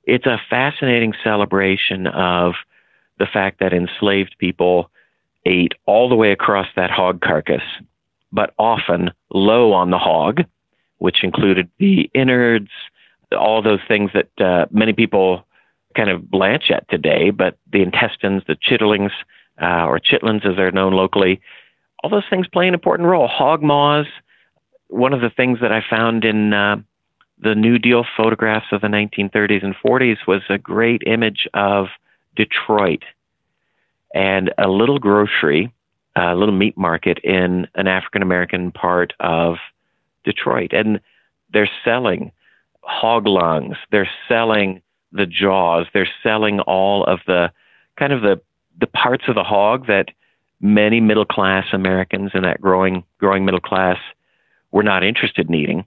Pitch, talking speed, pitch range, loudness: 100 Hz, 150 wpm, 95-110 Hz, -16 LUFS